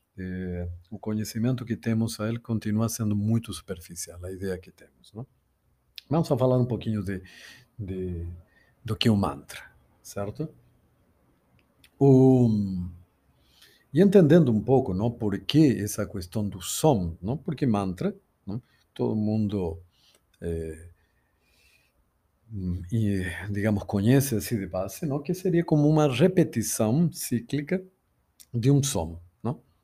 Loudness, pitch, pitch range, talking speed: -26 LUFS, 110 Hz, 95-130 Hz, 130 wpm